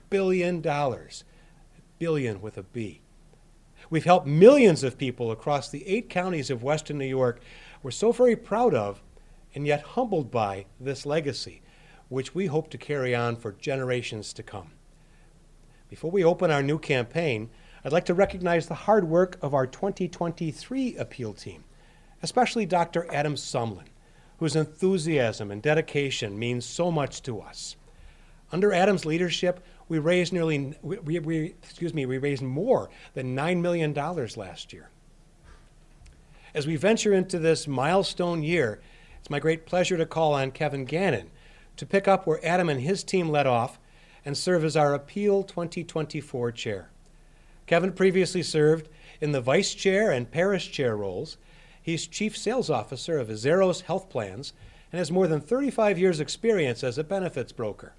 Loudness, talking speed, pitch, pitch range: -26 LUFS, 155 wpm, 160 Hz, 140-180 Hz